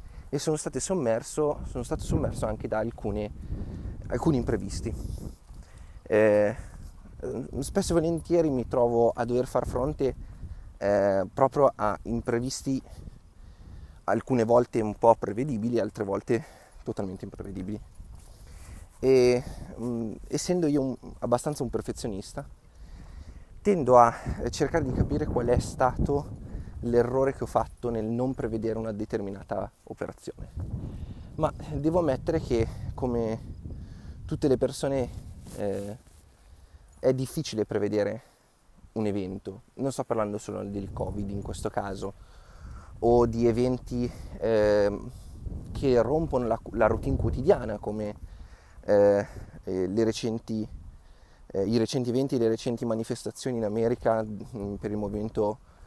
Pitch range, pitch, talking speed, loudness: 100-125 Hz, 110 Hz, 120 wpm, -28 LUFS